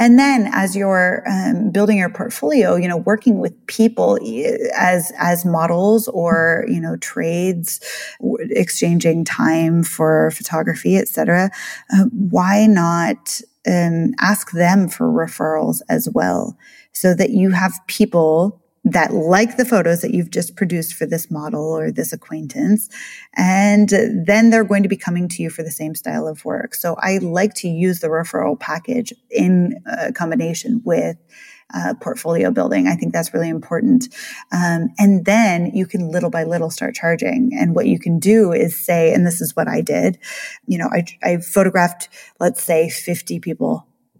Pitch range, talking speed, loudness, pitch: 165-220 Hz, 165 wpm, -17 LUFS, 185 Hz